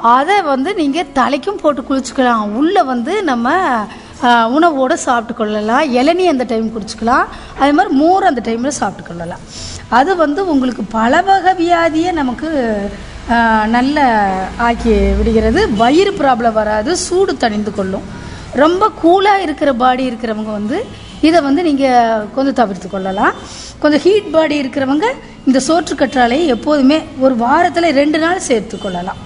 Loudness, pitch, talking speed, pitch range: -13 LUFS, 265 Hz, 130 wpm, 230-330 Hz